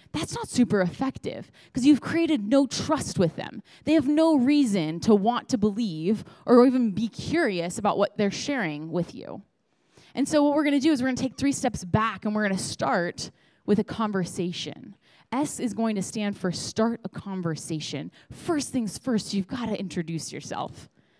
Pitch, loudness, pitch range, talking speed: 215 Hz, -26 LUFS, 185-260 Hz, 185 wpm